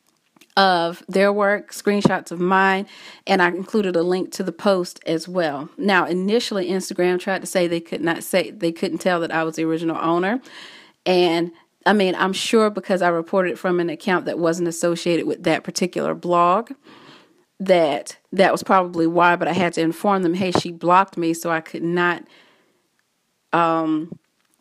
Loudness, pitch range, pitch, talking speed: -20 LUFS, 170-190 Hz, 180 Hz, 180 wpm